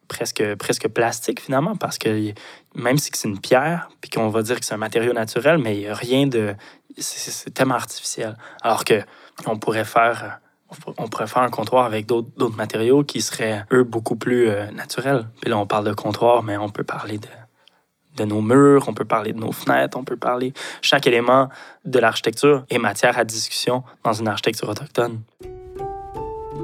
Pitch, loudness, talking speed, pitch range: 120 Hz, -20 LUFS, 185 wpm, 110-130 Hz